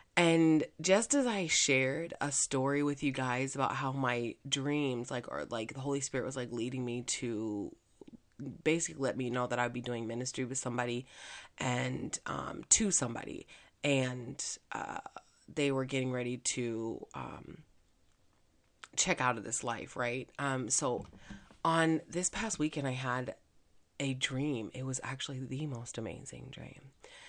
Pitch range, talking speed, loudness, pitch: 120-145 Hz, 155 wpm, -34 LUFS, 130 Hz